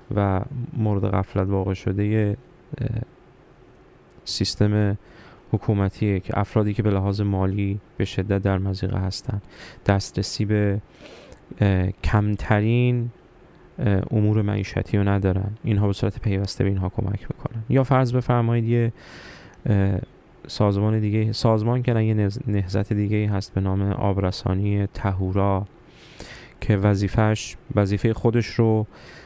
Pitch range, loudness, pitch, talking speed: 100-115 Hz, -23 LUFS, 105 Hz, 110 wpm